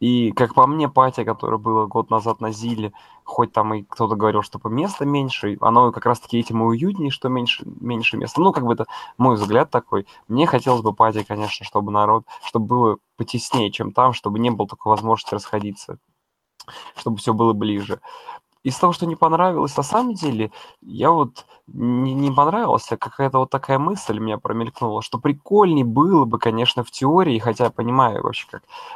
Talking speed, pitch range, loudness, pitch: 190 wpm, 110-140 Hz, -20 LUFS, 120 Hz